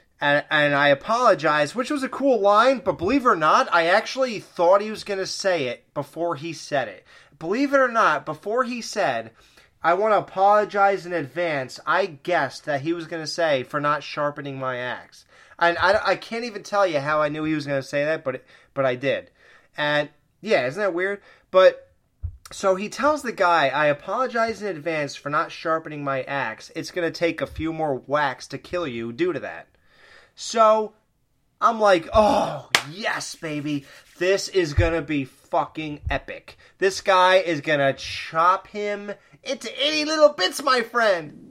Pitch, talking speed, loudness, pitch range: 175 Hz, 195 wpm, -22 LUFS, 150-215 Hz